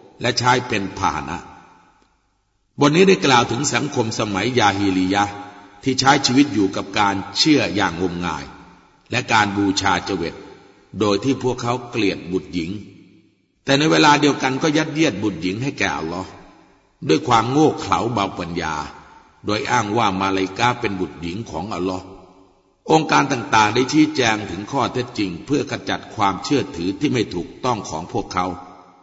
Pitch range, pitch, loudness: 95-125 Hz, 100 Hz, -19 LUFS